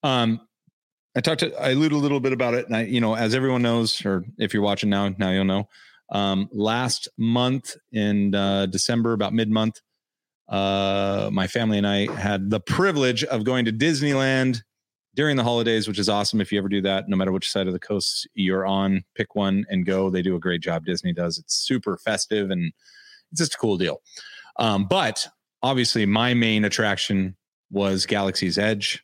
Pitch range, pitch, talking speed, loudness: 100-120 Hz, 105 Hz, 200 wpm, -23 LUFS